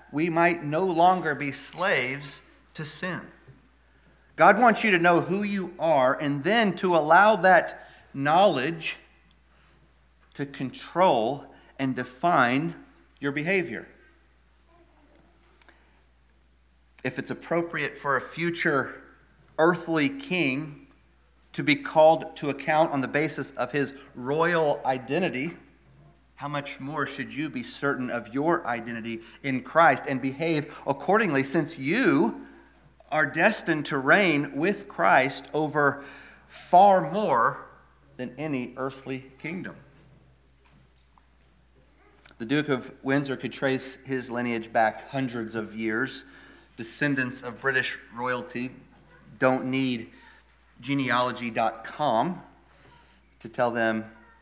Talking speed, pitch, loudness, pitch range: 110 wpm, 135 Hz, -25 LUFS, 115-155 Hz